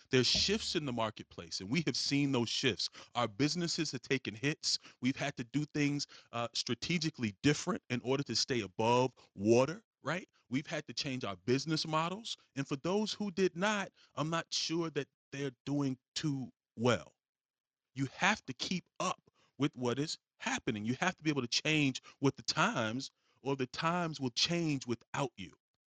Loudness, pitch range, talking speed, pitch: -35 LUFS, 125-160 Hz, 180 wpm, 140 Hz